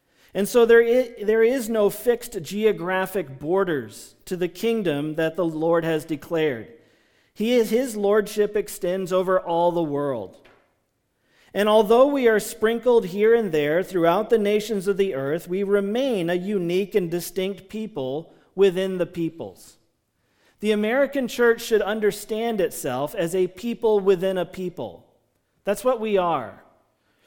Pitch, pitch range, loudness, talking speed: 200 Hz, 175-220 Hz, -22 LUFS, 140 wpm